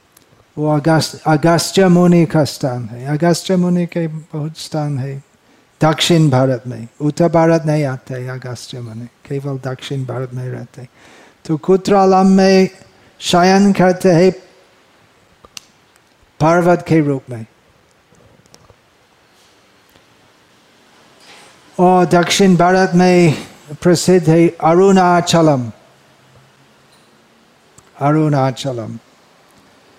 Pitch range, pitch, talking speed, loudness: 130-175 Hz, 155 Hz, 95 wpm, -14 LUFS